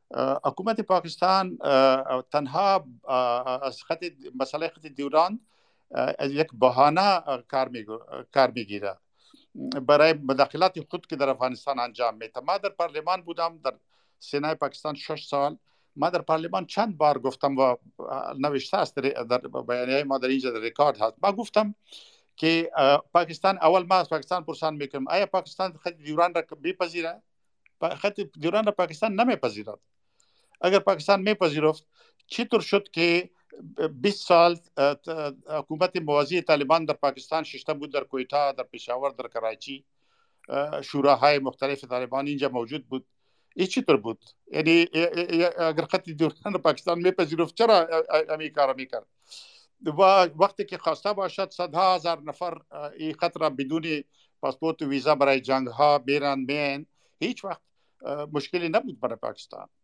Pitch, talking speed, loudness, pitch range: 155 Hz, 130 wpm, -25 LUFS, 140-180 Hz